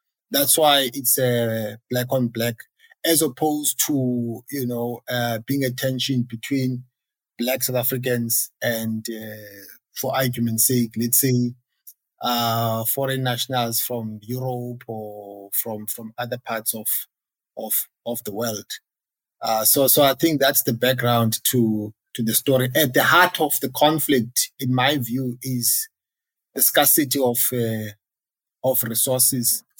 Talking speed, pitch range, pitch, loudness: 145 wpm, 115-135 Hz, 125 Hz, -20 LUFS